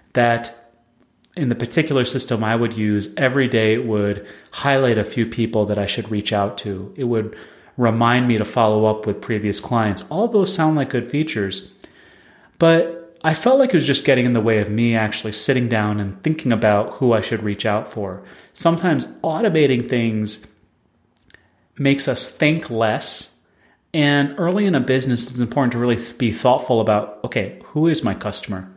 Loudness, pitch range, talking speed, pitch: -19 LUFS, 105-135 Hz, 180 wpm, 115 Hz